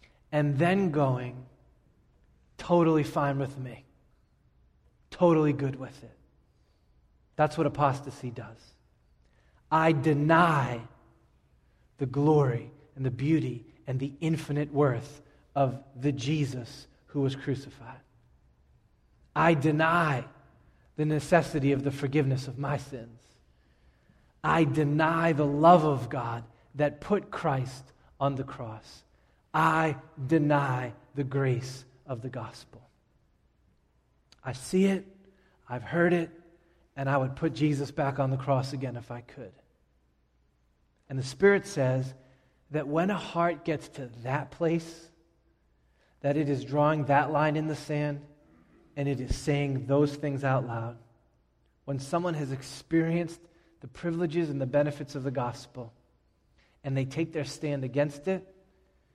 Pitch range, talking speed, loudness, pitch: 120-155 Hz, 130 wpm, -28 LUFS, 140 Hz